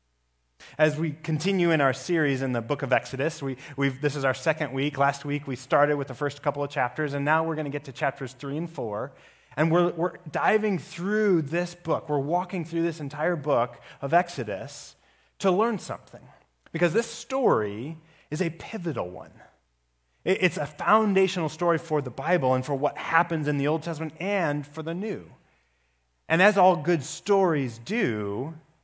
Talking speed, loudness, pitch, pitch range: 185 wpm, -26 LUFS, 155 Hz, 135-175 Hz